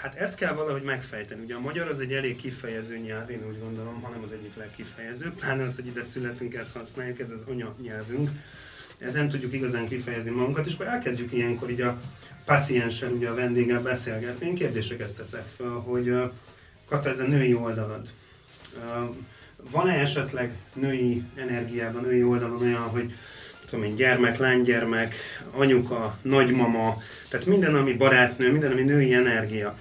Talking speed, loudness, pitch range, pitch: 160 wpm, -26 LUFS, 115-135 Hz, 125 Hz